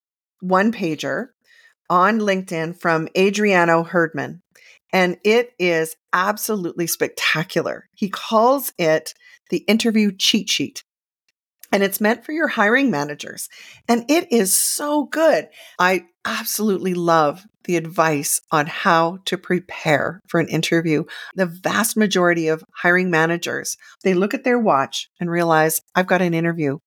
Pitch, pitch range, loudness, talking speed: 180 Hz, 165-215 Hz, -19 LUFS, 135 wpm